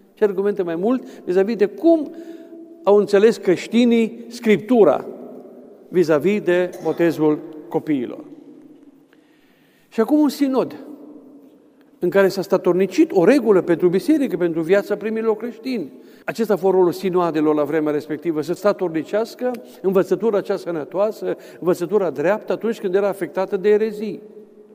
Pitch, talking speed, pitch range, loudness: 205 Hz, 130 wpm, 180-240 Hz, -19 LUFS